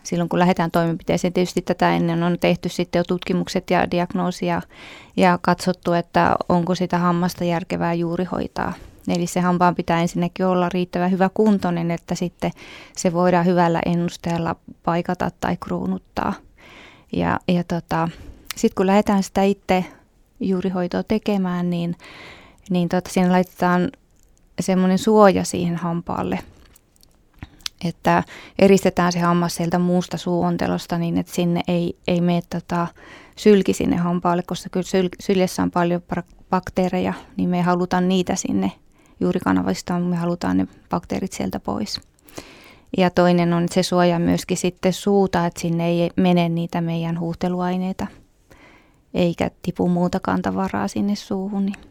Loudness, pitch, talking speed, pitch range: -21 LUFS, 180 Hz, 140 wpm, 170-185 Hz